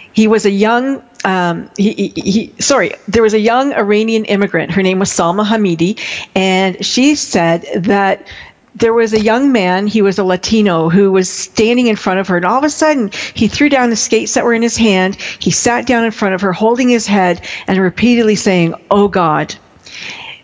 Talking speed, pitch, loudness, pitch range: 205 wpm, 210 Hz, -12 LUFS, 190-230 Hz